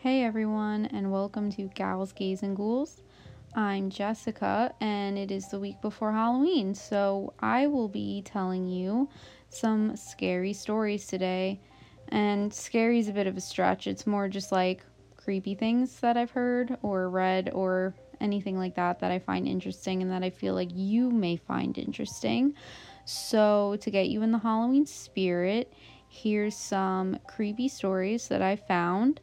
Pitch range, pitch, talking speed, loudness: 185-225 Hz, 200 Hz, 160 wpm, -29 LUFS